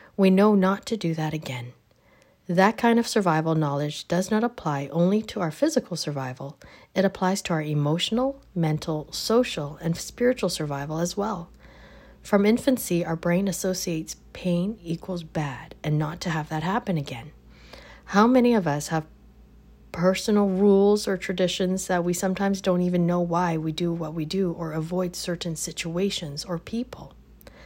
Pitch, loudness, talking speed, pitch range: 175 Hz, -25 LUFS, 160 wpm, 155-195 Hz